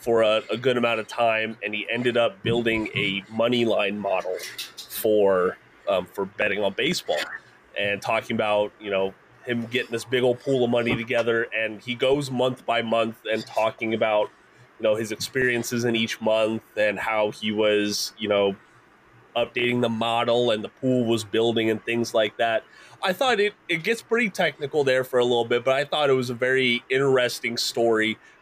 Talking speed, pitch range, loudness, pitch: 190 wpm, 110-125 Hz, -24 LUFS, 115 Hz